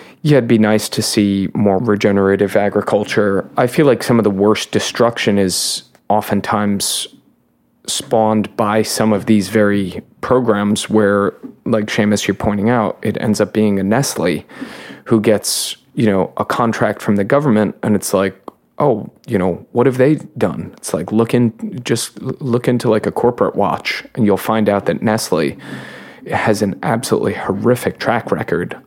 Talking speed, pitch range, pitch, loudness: 165 wpm, 100-110 Hz, 105 Hz, -16 LUFS